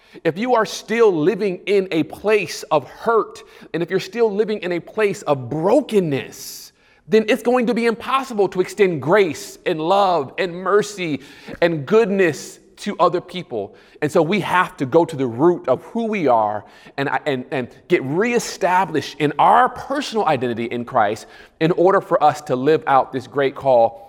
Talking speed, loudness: 180 wpm, -19 LUFS